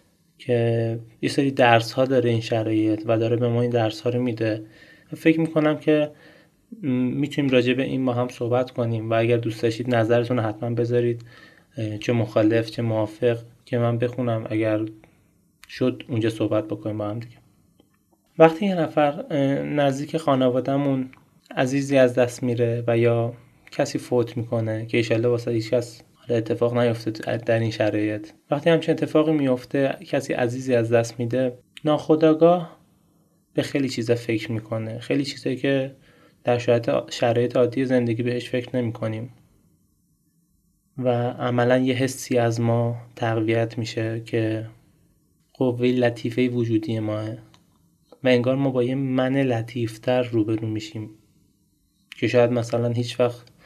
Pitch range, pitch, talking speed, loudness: 115-135 Hz, 120 Hz, 140 wpm, -23 LUFS